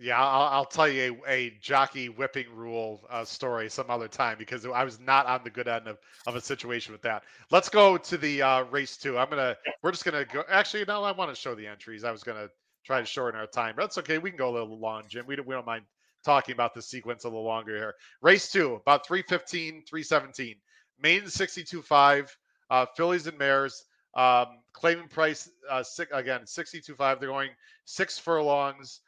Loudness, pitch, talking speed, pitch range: -27 LUFS, 135 Hz, 220 wpm, 120-160 Hz